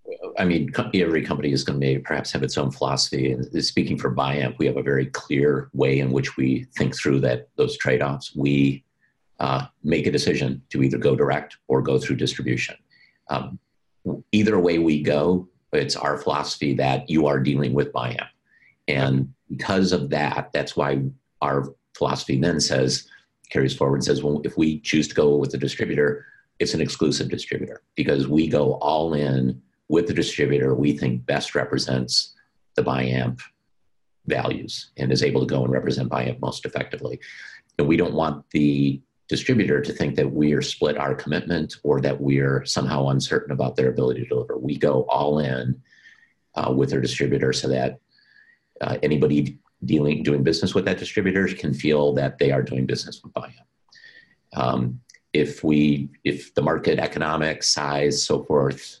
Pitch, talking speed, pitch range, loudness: 70 Hz, 175 wpm, 65-75 Hz, -23 LUFS